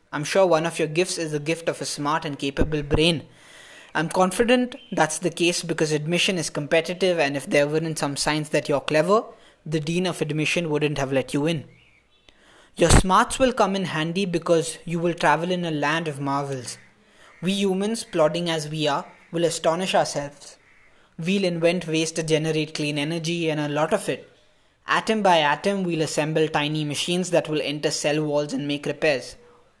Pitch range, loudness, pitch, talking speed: 150-175 Hz, -23 LUFS, 160 Hz, 185 wpm